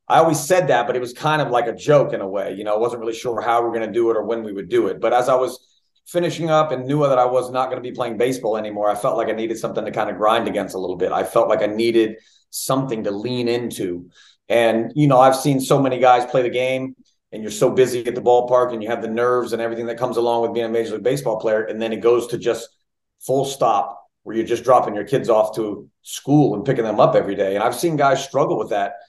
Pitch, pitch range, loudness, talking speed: 120 Hz, 115-130 Hz, -19 LUFS, 290 wpm